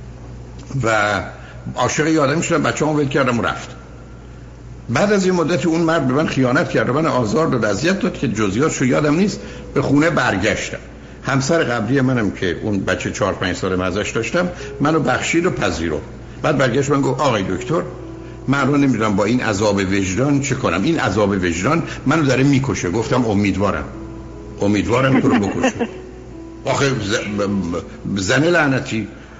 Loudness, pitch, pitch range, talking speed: -18 LUFS, 130 Hz, 105-145 Hz, 155 wpm